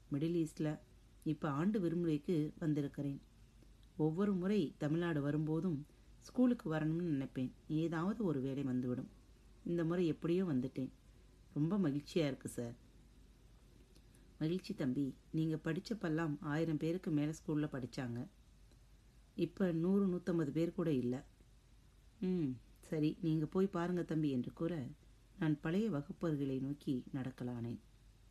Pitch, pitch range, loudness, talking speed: 155 Hz, 130-170 Hz, -39 LUFS, 110 wpm